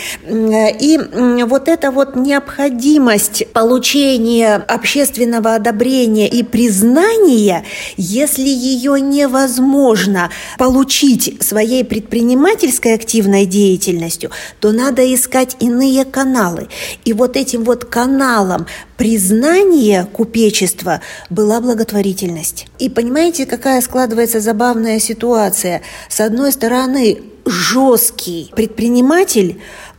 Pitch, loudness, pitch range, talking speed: 235 Hz, -12 LUFS, 215-265 Hz, 85 wpm